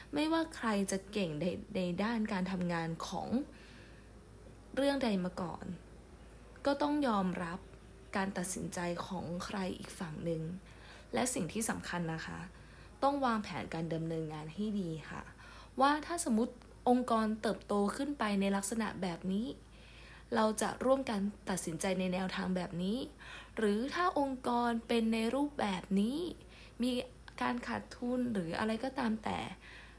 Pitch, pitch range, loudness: 205 Hz, 180-245 Hz, -36 LUFS